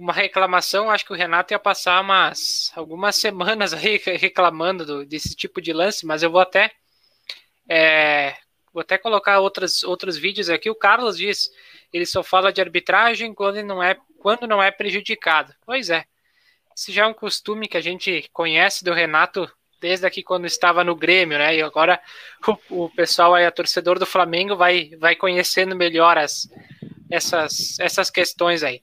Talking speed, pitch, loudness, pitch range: 175 wpm, 180 Hz, -19 LUFS, 170-200 Hz